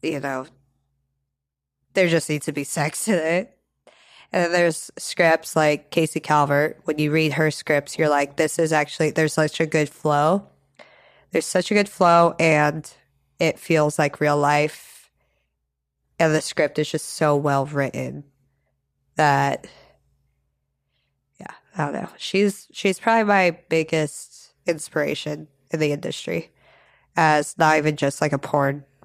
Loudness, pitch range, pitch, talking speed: -21 LUFS, 140-160 Hz, 150 Hz, 150 wpm